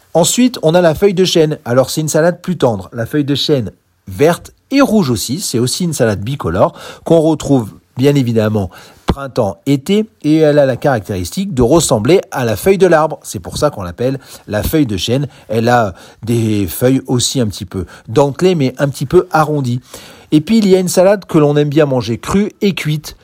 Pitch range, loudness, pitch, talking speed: 115-160 Hz, -13 LUFS, 140 Hz, 210 wpm